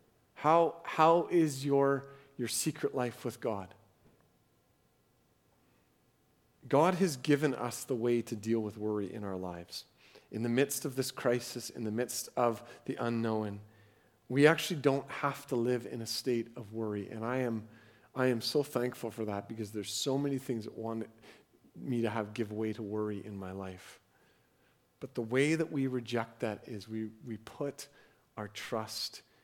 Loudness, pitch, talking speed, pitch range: -34 LUFS, 120 Hz, 170 wpm, 110-140 Hz